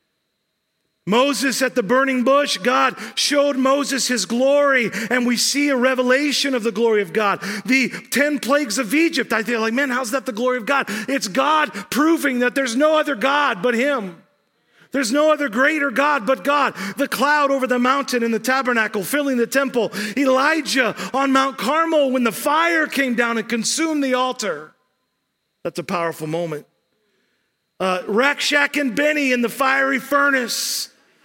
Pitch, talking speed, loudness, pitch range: 265 Hz, 170 wpm, -18 LUFS, 235-280 Hz